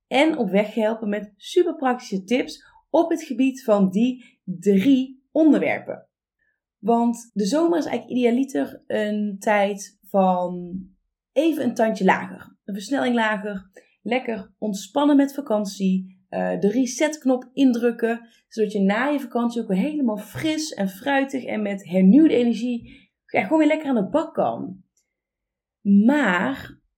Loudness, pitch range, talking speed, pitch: -22 LUFS, 205-270 Hz, 135 wpm, 235 Hz